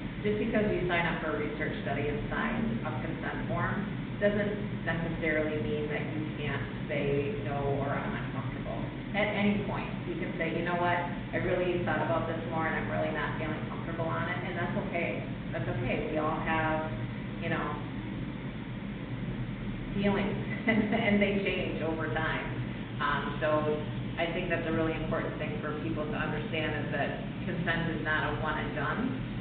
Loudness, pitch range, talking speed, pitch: -32 LUFS, 150-185 Hz, 175 wpm, 160 Hz